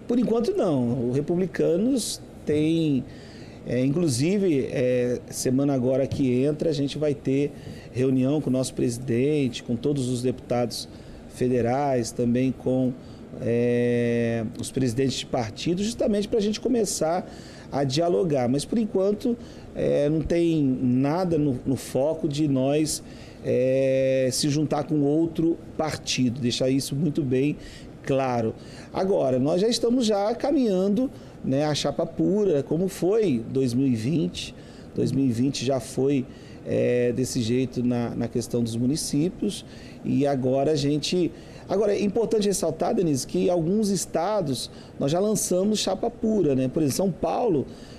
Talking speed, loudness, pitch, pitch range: 140 wpm, -24 LUFS, 140 Hz, 125-170 Hz